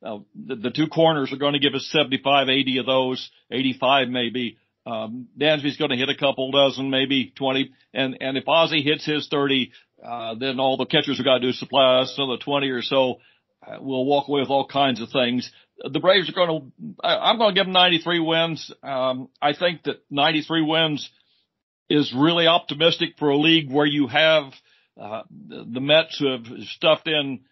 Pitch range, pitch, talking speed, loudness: 130-155 Hz, 140 Hz, 205 wpm, -21 LUFS